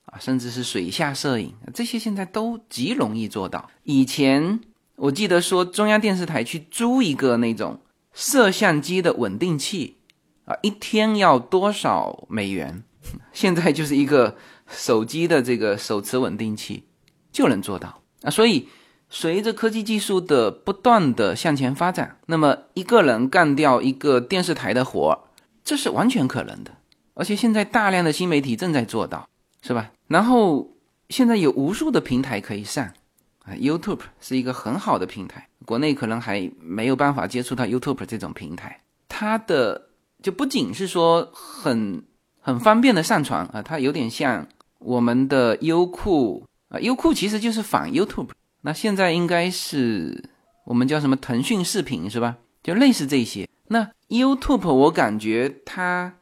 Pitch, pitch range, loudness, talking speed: 165 Hz, 130-215 Hz, -21 LUFS, 265 characters per minute